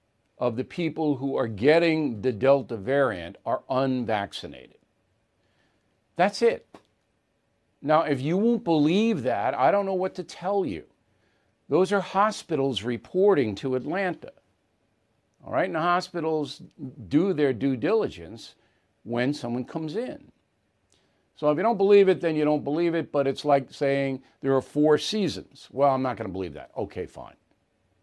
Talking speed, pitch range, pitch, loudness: 155 wpm, 130-170 Hz, 140 Hz, -25 LUFS